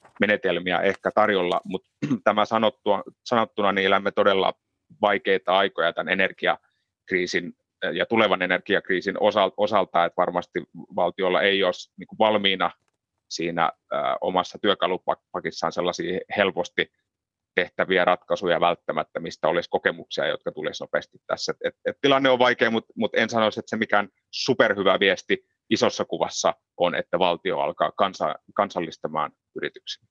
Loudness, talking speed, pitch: -24 LUFS, 115 wpm, 125 Hz